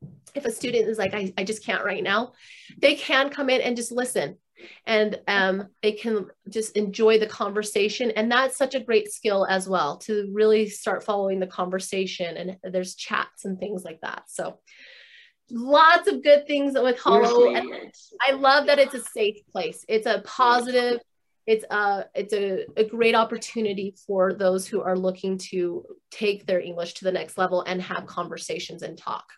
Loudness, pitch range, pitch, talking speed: -23 LUFS, 190-250 Hz, 215 Hz, 180 wpm